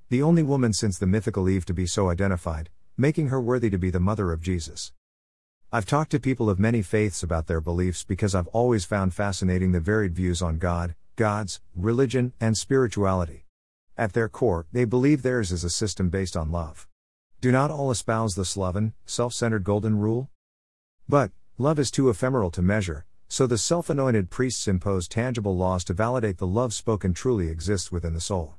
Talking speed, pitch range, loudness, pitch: 190 wpm, 90-120 Hz, -25 LUFS, 100 Hz